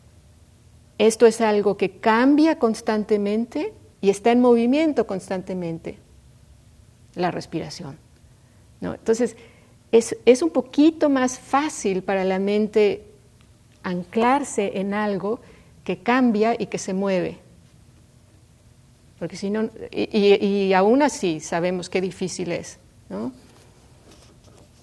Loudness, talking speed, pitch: -21 LUFS, 110 wpm, 195 Hz